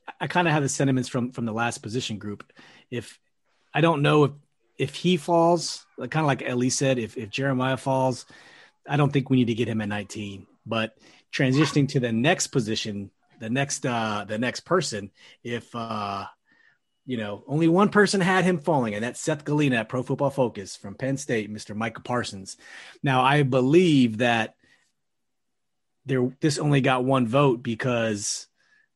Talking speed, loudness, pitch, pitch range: 180 wpm, -24 LUFS, 130 Hz, 115-145 Hz